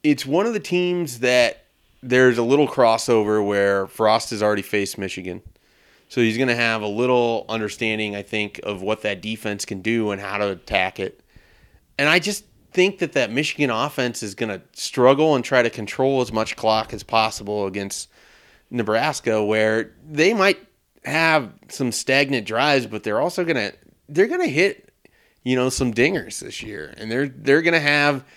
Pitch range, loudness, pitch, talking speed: 105-145 Hz, -21 LUFS, 120 Hz, 185 wpm